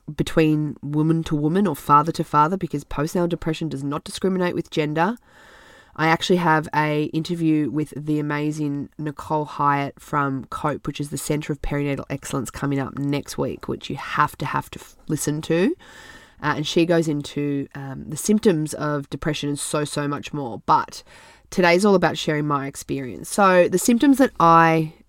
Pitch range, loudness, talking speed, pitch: 145-165 Hz, -22 LUFS, 180 wpm, 150 Hz